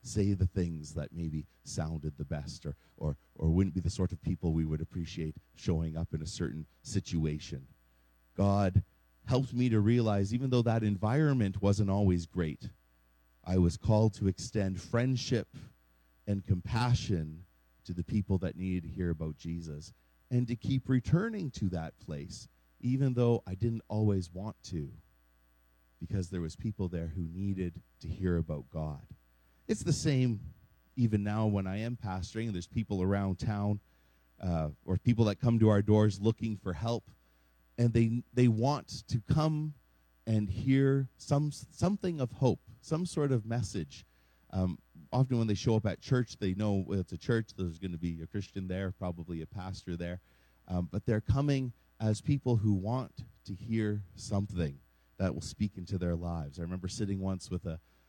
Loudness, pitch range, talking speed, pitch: -33 LUFS, 80-115 Hz, 175 wpm, 95 Hz